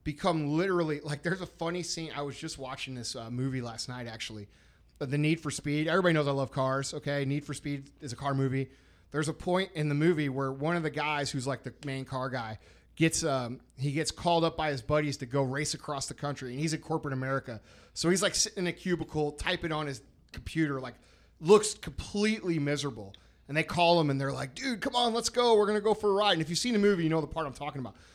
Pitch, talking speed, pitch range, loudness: 145 Hz, 250 wpm, 135-170 Hz, -30 LUFS